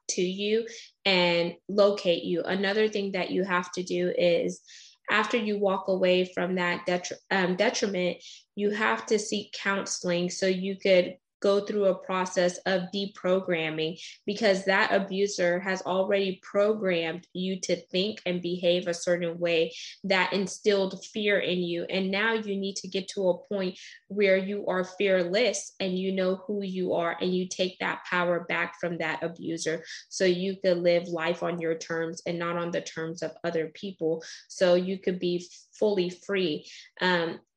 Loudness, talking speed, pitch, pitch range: -28 LUFS, 170 wpm, 185 Hz, 175-195 Hz